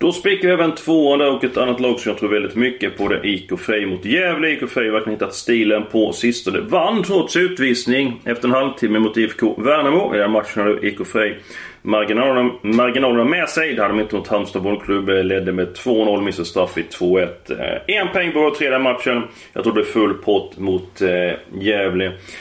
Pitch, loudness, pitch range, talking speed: 115 Hz, -18 LUFS, 105-130 Hz, 195 wpm